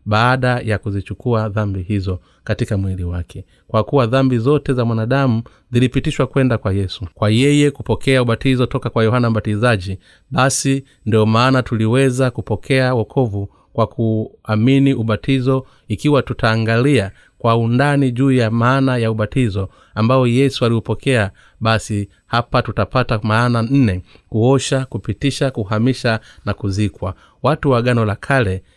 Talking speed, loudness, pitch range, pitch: 130 wpm, -17 LUFS, 110-130 Hz, 115 Hz